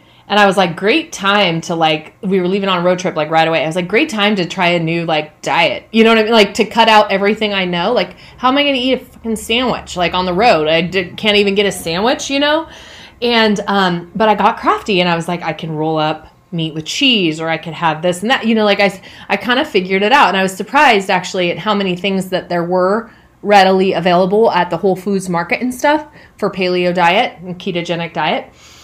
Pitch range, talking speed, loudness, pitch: 175-220 Hz, 260 wpm, -14 LUFS, 190 Hz